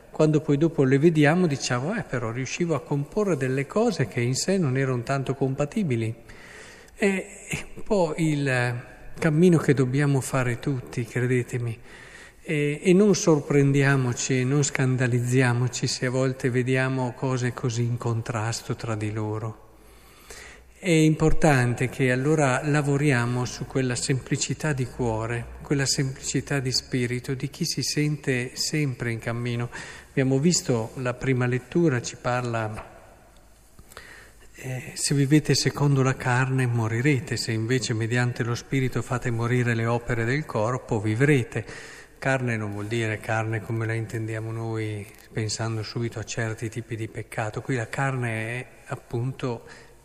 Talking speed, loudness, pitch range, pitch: 140 wpm, -25 LUFS, 120-145 Hz, 130 Hz